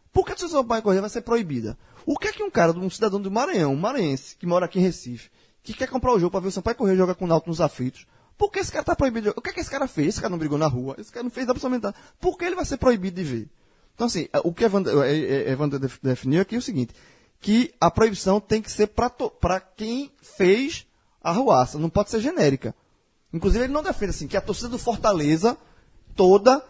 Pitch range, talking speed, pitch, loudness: 165-245 Hz, 255 wpm, 200 Hz, -23 LUFS